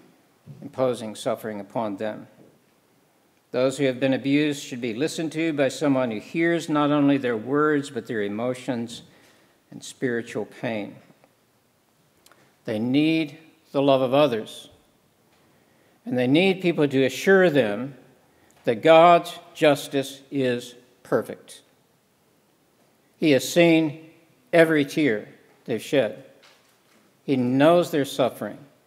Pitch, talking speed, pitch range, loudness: 140 Hz, 115 wpm, 125-160 Hz, -23 LUFS